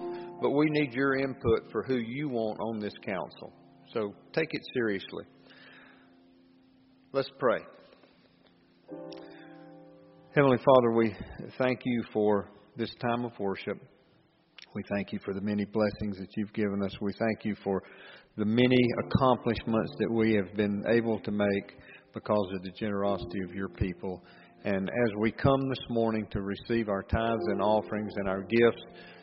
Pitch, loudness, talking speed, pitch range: 105 Hz, -30 LUFS, 155 wpm, 100-115 Hz